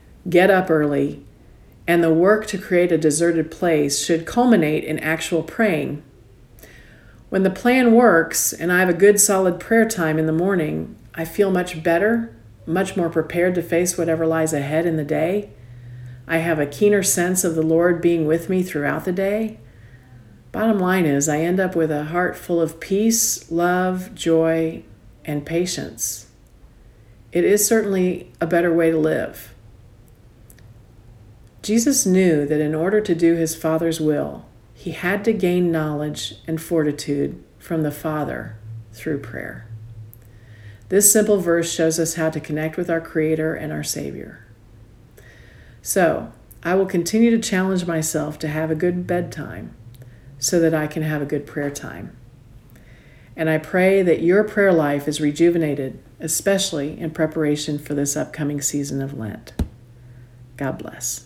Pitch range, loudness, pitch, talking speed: 140-180 Hz, -20 LUFS, 160 Hz, 160 wpm